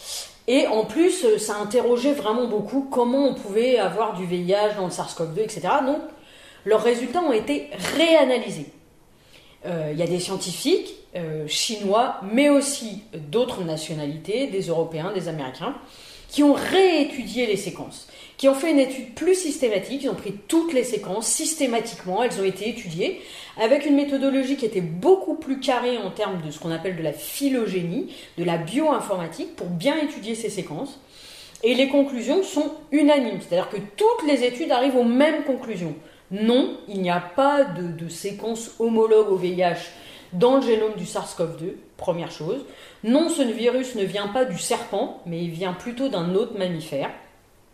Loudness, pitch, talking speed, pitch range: -23 LUFS, 225 Hz, 170 wpm, 185-275 Hz